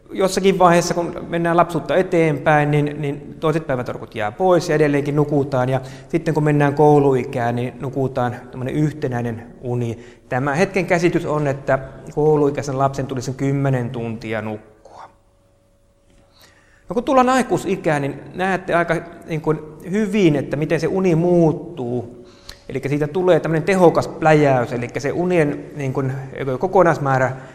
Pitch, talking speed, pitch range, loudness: 145 Hz, 125 wpm, 125-165 Hz, -19 LUFS